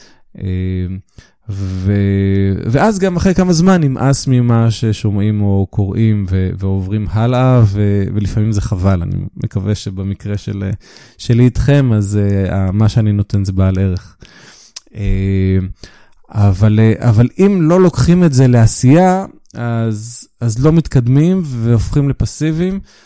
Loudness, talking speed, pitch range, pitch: -13 LUFS, 115 wpm, 100-130 Hz, 110 Hz